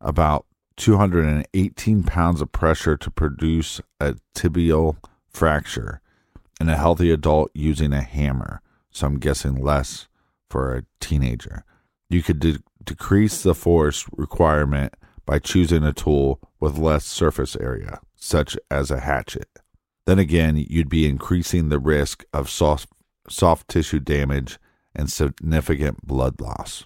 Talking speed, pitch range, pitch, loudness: 130 wpm, 70-85 Hz, 75 Hz, -21 LUFS